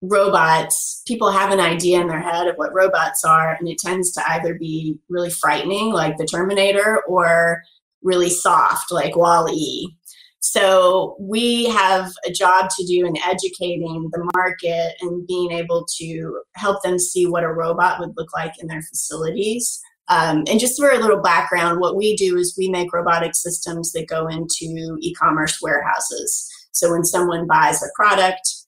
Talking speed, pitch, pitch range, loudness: 170 wpm, 175 Hz, 165-190 Hz, -18 LUFS